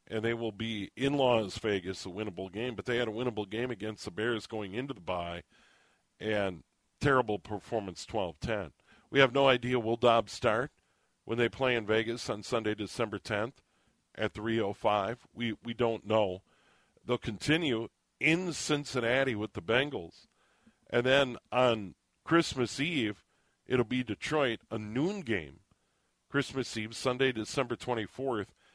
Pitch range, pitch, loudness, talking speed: 105-125 Hz, 115 Hz, -32 LUFS, 160 wpm